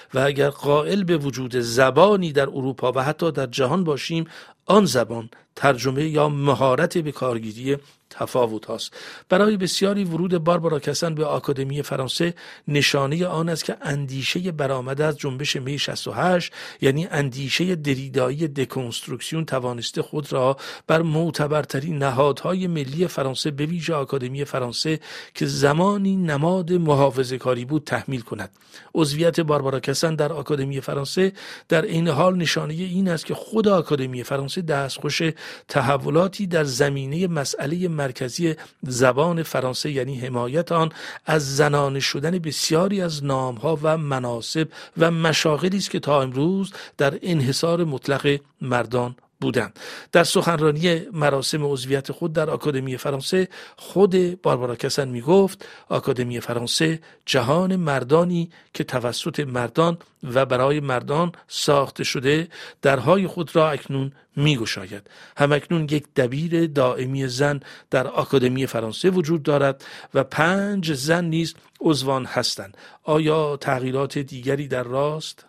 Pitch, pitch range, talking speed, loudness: 145 Hz, 135-165 Hz, 130 wpm, -22 LUFS